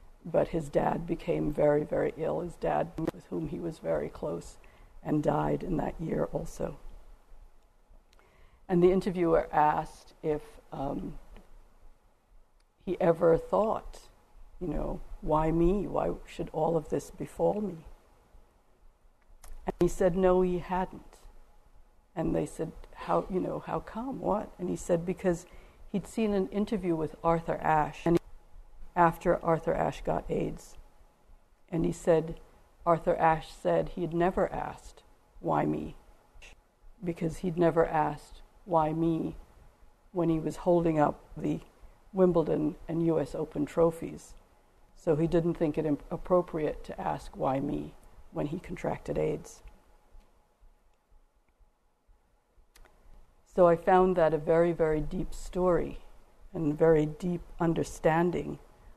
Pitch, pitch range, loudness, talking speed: 165 Hz, 155-180 Hz, -30 LUFS, 130 wpm